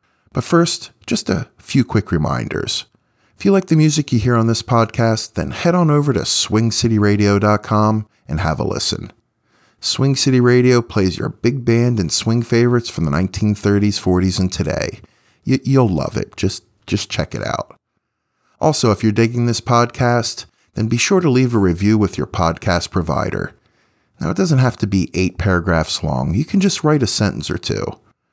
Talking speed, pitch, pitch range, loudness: 180 wpm, 115 Hz, 100-125 Hz, -17 LUFS